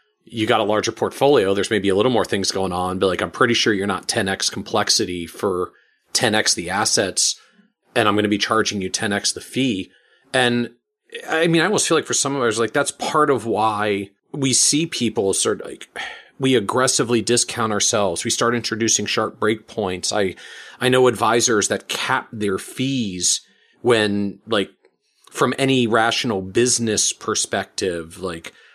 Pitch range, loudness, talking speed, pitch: 100-125 Hz, -19 LUFS, 175 wpm, 110 Hz